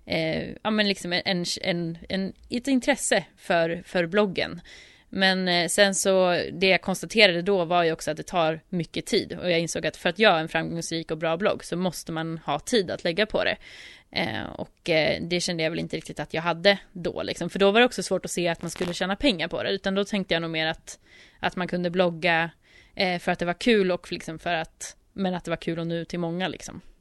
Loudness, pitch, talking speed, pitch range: -25 LUFS, 175 Hz, 245 wpm, 165-190 Hz